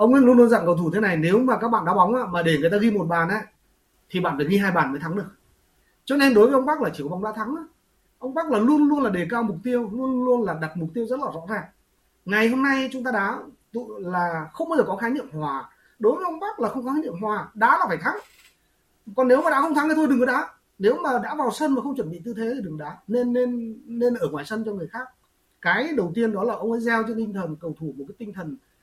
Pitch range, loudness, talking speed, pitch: 185-255 Hz, -23 LUFS, 300 wpm, 230 Hz